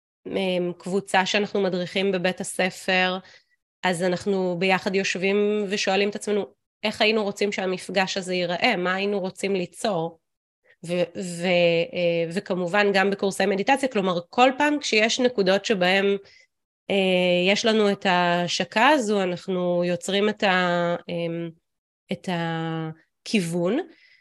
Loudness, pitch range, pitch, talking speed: -23 LUFS, 180-205 Hz, 190 Hz, 115 wpm